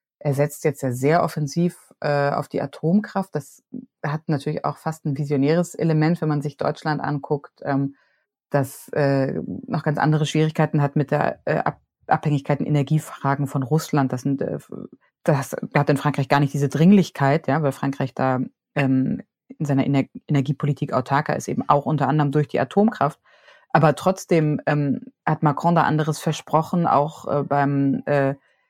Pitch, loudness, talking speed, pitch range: 150 Hz, -22 LUFS, 165 wpm, 140-155 Hz